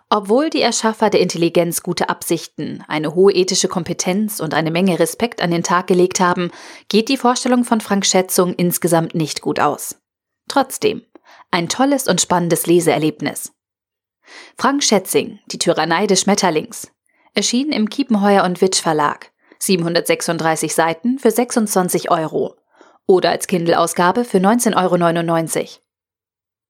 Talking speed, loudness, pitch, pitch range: 135 wpm, -16 LUFS, 185 Hz, 170-220 Hz